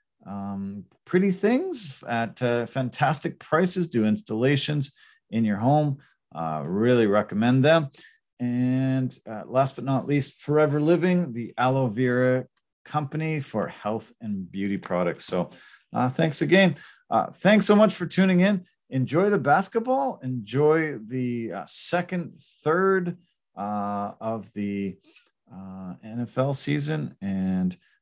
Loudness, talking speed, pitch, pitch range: -24 LUFS, 125 wpm, 130 Hz, 110-165 Hz